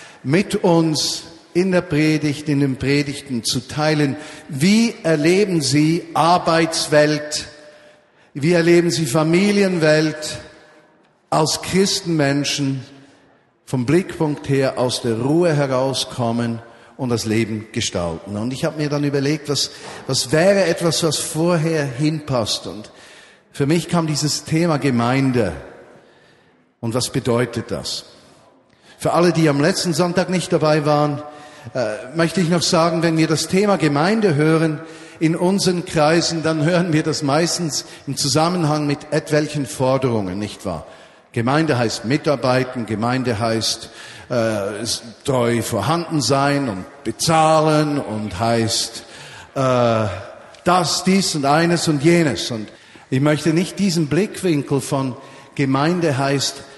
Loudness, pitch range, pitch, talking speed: -18 LUFS, 130-165 Hz, 150 Hz, 125 wpm